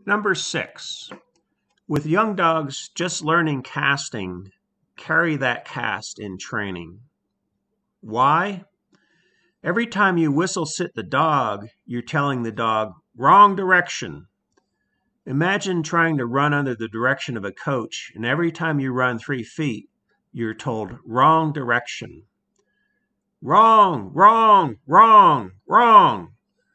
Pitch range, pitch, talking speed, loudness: 115-185 Hz, 150 Hz, 115 wpm, -19 LUFS